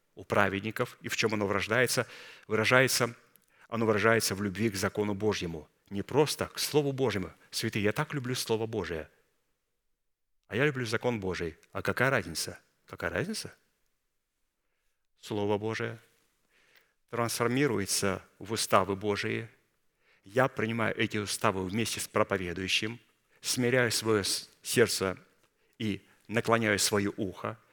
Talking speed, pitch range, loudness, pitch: 120 wpm, 105-120 Hz, -30 LUFS, 110 Hz